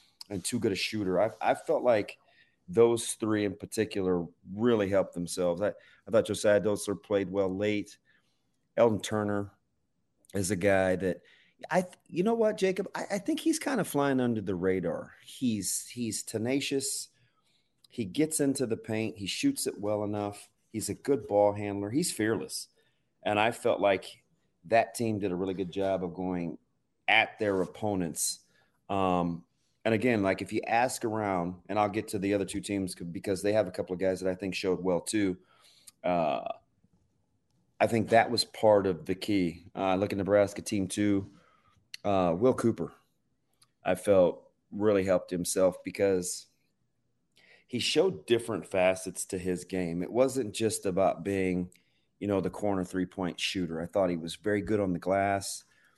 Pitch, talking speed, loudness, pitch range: 100 Hz, 175 wpm, -30 LUFS, 95-115 Hz